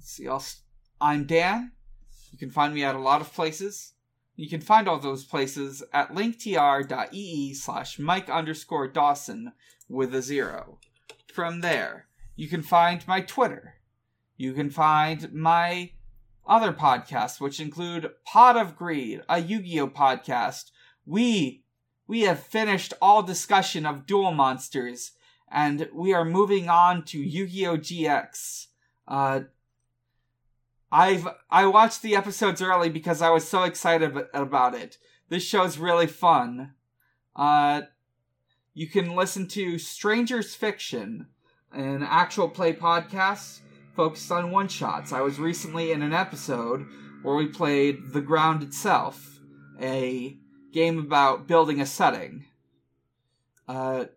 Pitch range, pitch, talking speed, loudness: 130-180 Hz, 155 Hz, 135 wpm, -24 LUFS